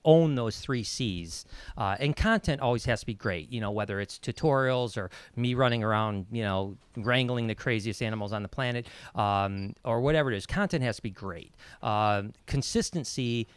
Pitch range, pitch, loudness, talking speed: 100-125 Hz, 115 Hz, -29 LUFS, 185 wpm